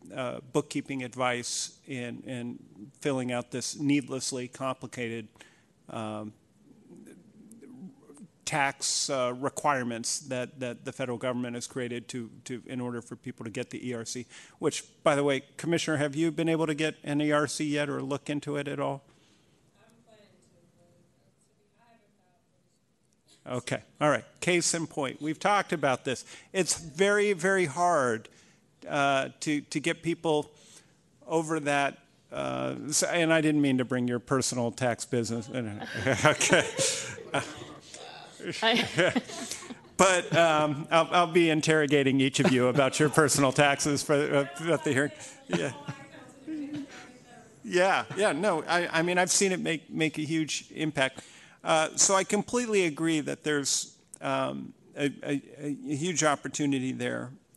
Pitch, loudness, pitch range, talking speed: 145 Hz, -28 LUFS, 125-165 Hz, 135 wpm